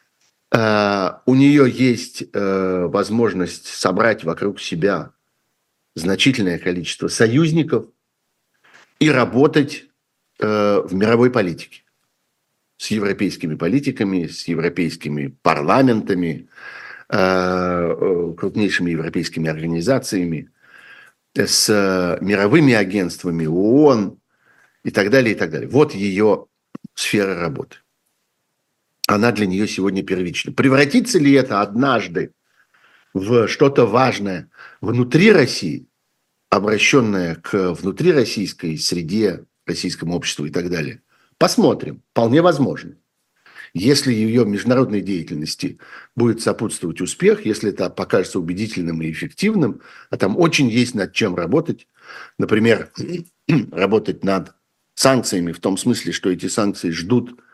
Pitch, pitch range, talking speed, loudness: 100 Hz, 90-125 Hz, 105 wpm, -18 LUFS